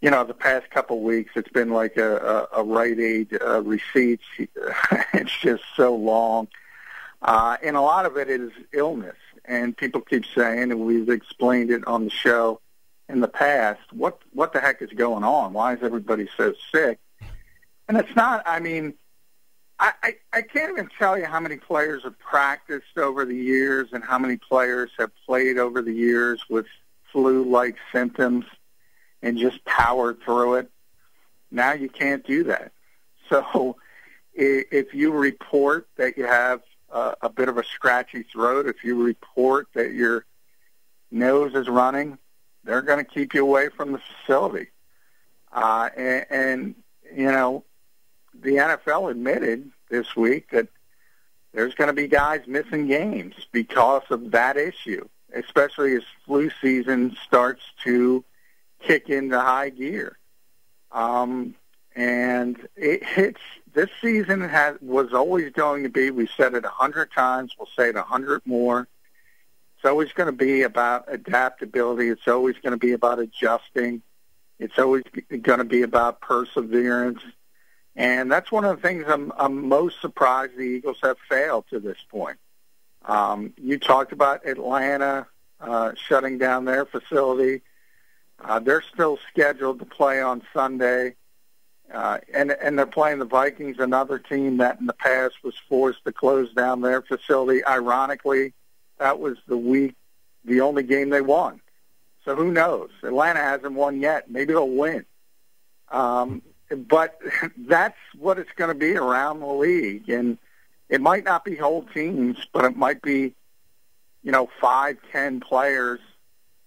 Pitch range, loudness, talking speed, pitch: 120-140 Hz, -22 LUFS, 160 wpm, 130 Hz